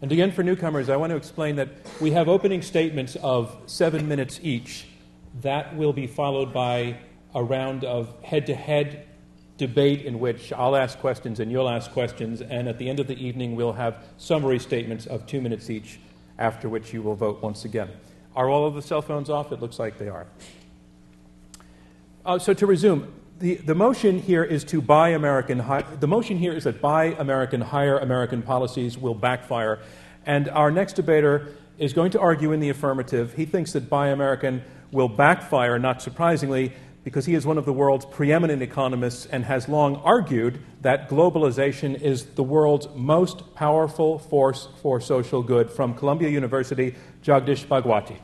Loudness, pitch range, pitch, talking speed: -23 LUFS, 120-150 Hz, 135 Hz, 180 wpm